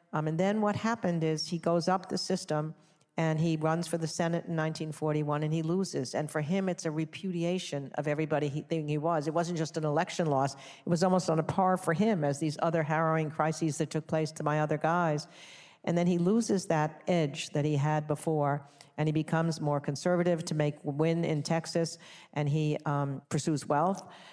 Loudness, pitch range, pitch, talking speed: -31 LUFS, 150-175 Hz, 160 Hz, 205 wpm